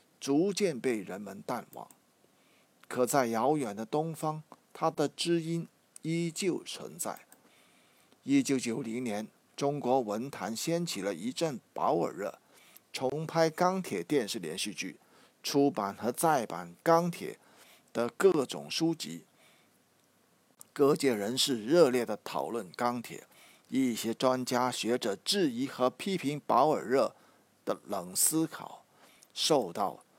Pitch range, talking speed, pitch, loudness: 125-170 Hz, 180 characters per minute, 145 Hz, -31 LUFS